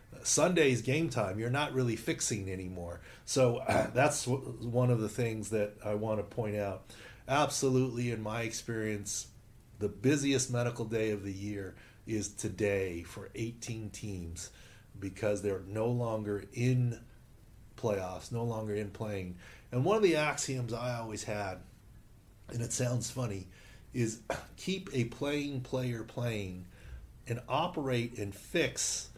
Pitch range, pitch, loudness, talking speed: 105-125 Hz, 115 Hz, -34 LUFS, 140 wpm